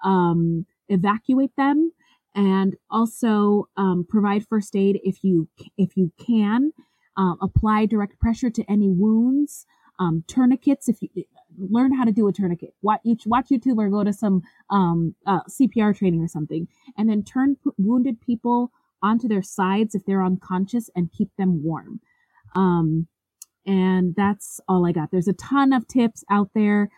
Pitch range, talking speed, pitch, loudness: 185-240 Hz, 160 wpm, 205 Hz, -22 LUFS